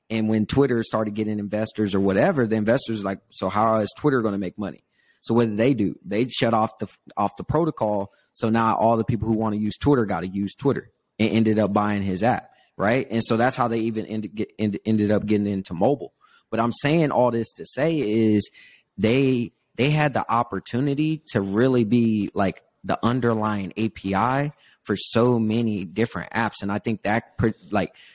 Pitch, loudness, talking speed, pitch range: 110 Hz, -23 LUFS, 205 wpm, 105-120 Hz